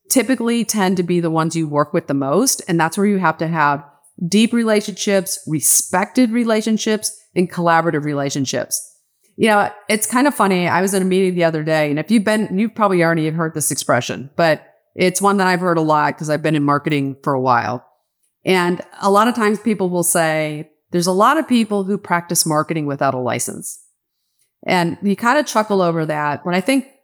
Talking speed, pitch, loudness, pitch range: 210 wpm, 180 Hz, -17 LUFS, 155-210 Hz